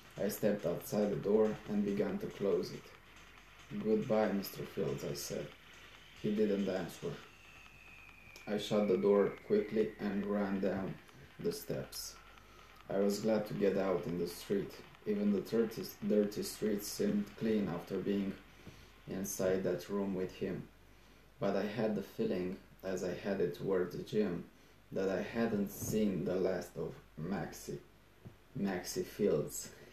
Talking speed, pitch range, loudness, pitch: 140 wpm, 95-110 Hz, -37 LUFS, 100 Hz